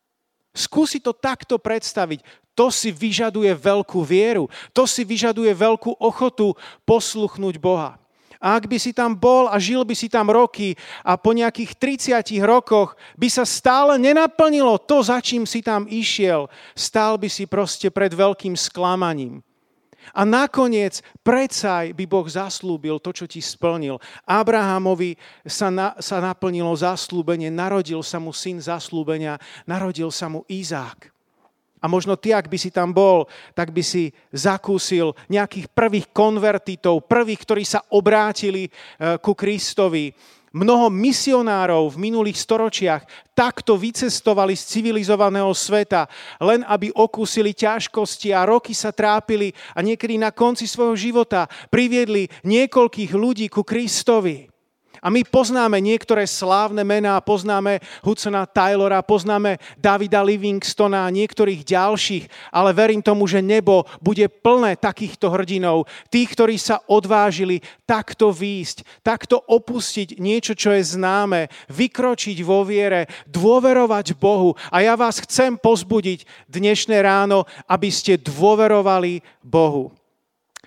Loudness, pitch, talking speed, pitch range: -19 LUFS, 205 Hz, 130 wpm, 185-225 Hz